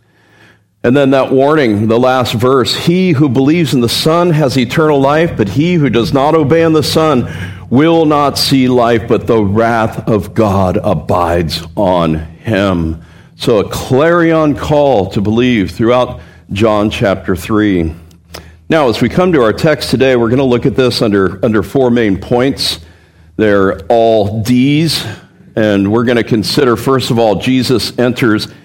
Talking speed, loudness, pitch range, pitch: 165 wpm, -11 LUFS, 100-135 Hz, 120 Hz